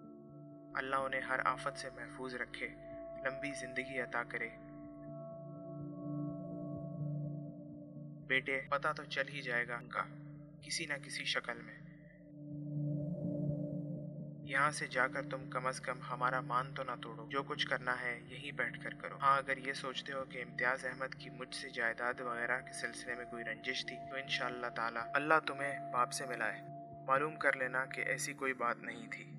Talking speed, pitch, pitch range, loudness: 165 wpm, 140 Hz, 130-150 Hz, -38 LUFS